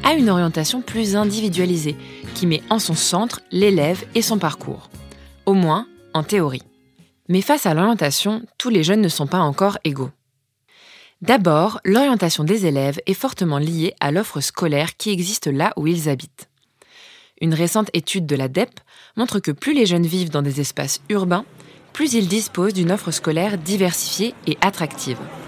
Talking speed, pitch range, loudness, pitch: 165 wpm, 150-210 Hz, -19 LUFS, 180 Hz